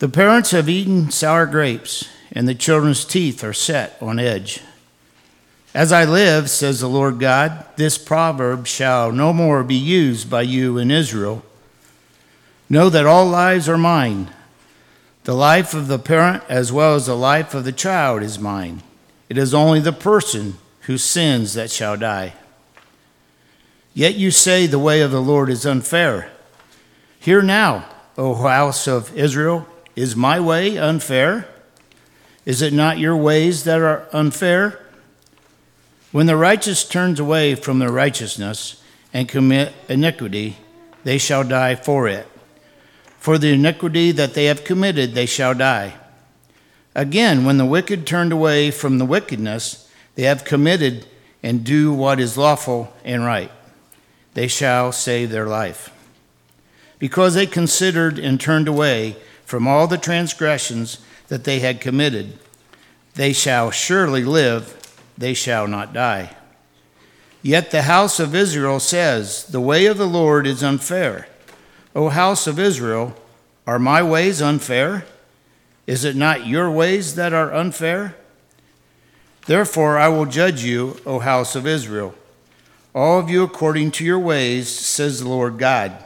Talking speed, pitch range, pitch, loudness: 150 wpm, 120-160 Hz, 140 Hz, -17 LUFS